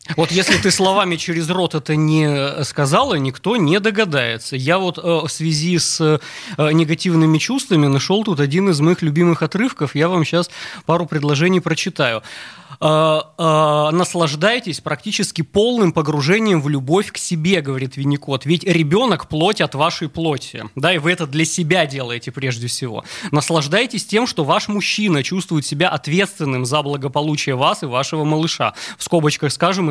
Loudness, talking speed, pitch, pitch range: -17 LUFS, 150 wpm, 160 Hz, 150-180 Hz